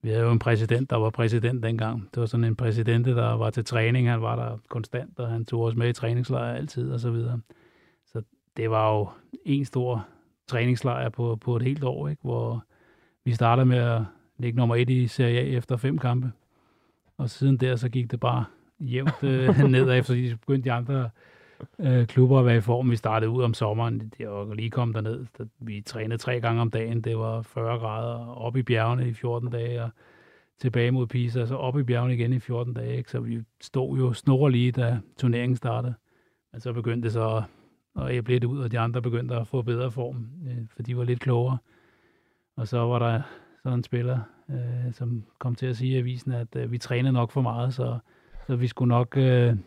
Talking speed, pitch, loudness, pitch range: 210 wpm, 120 Hz, -26 LUFS, 115-125 Hz